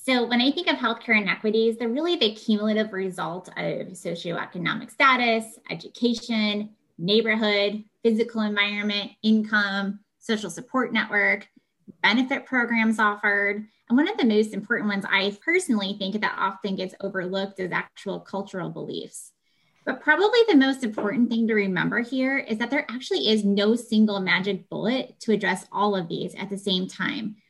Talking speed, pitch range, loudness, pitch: 155 wpm, 195-235 Hz, -24 LUFS, 215 Hz